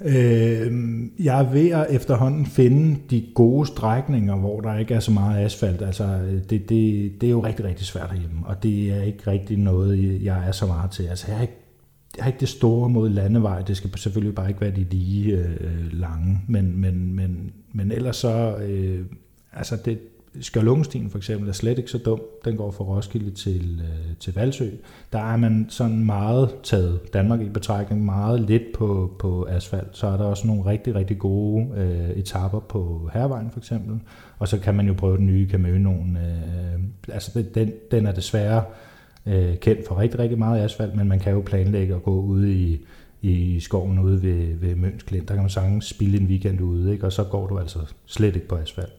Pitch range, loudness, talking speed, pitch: 95-115 Hz, -23 LUFS, 205 wpm, 100 Hz